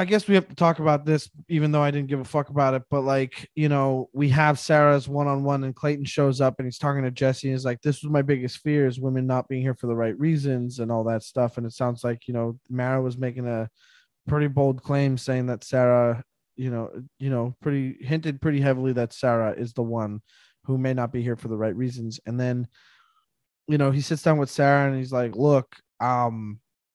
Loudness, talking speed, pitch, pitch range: -24 LUFS, 240 wpm, 130 Hz, 125-145 Hz